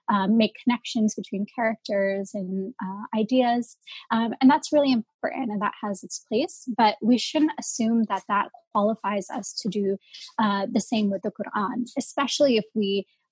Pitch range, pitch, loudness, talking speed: 205-255 Hz, 225 Hz, -25 LUFS, 165 wpm